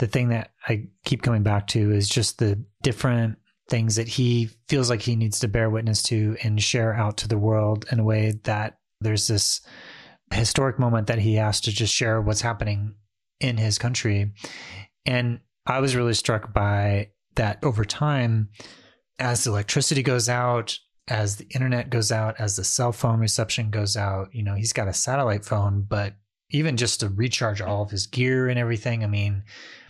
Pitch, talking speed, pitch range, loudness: 110 Hz, 190 wpm, 105-120 Hz, -24 LUFS